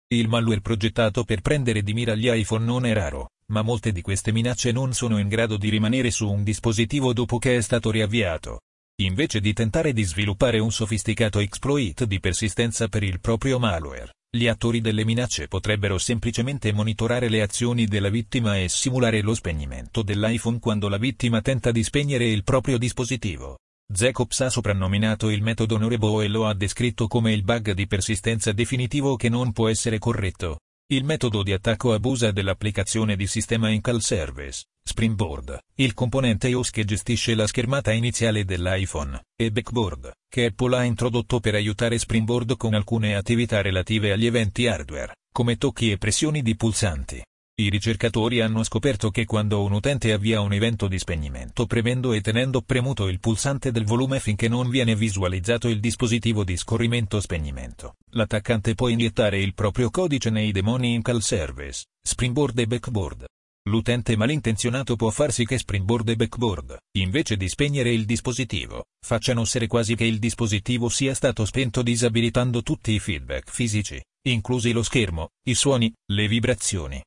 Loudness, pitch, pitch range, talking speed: -23 LUFS, 115 Hz, 105-120 Hz, 165 wpm